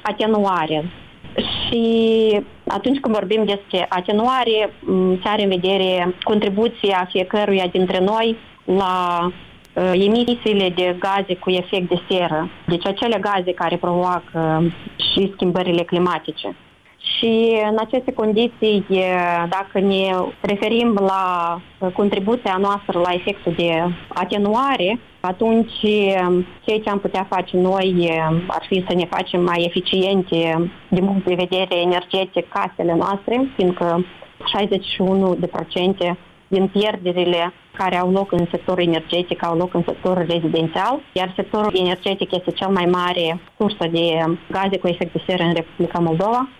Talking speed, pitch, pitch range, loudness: 125 wpm, 185 Hz, 175-205 Hz, -19 LUFS